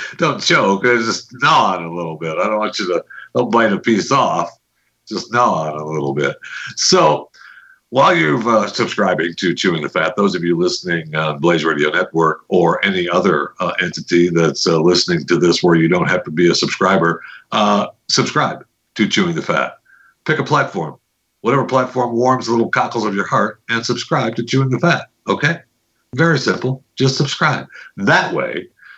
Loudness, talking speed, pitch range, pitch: -16 LUFS, 190 wpm, 85-130 Hz, 115 Hz